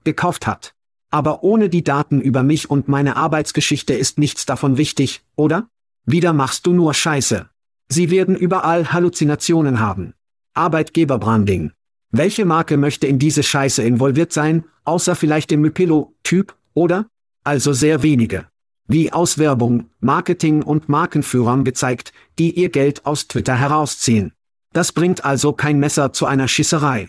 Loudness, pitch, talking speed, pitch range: -17 LUFS, 150 Hz, 140 wpm, 135-165 Hz